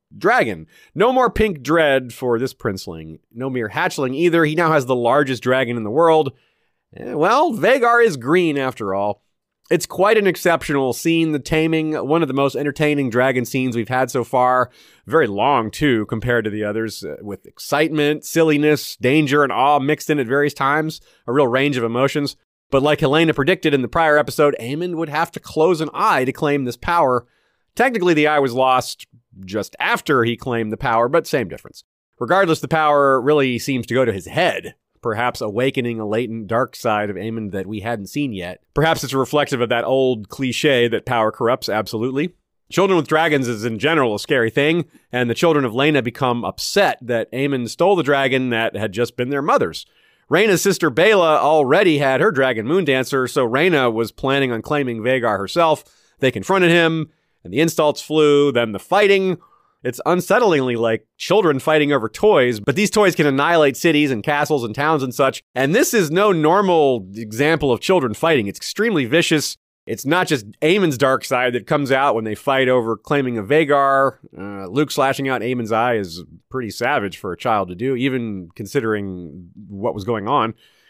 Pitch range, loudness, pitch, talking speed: 120-155 Hz, -18 LUFS, 135 Hz, 190 wpm